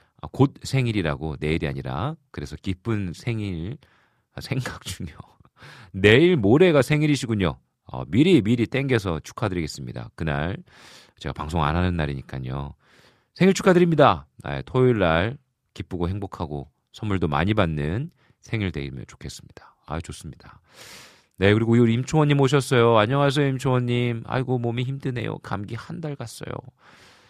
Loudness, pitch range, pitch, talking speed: -23 LUFS, 85-130 Hz, 115 Hz, 315 characters per minute